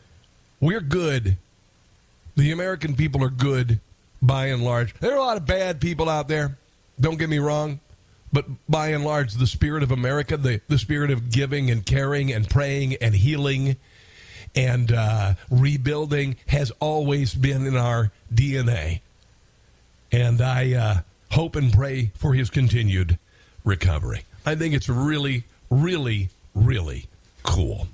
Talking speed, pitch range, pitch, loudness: 145 wpm, 105-145 Hz, 130 Hz, -23 LUFS